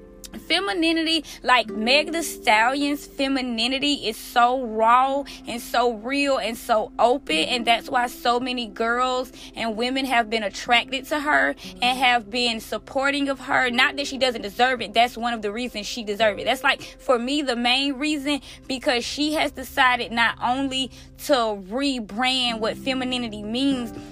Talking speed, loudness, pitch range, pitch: 165 wpm, -22 LUFS, 235-275 Hz, 250 Hz